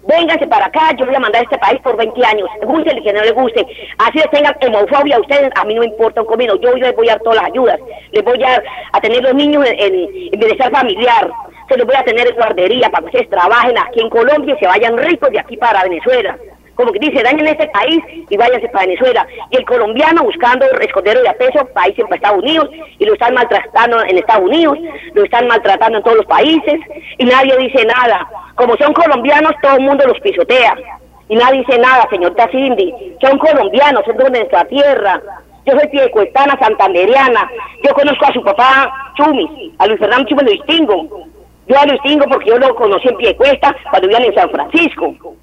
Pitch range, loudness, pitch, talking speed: 235-325 Hz, -11 LUFS, 275 Hz, 215 wpm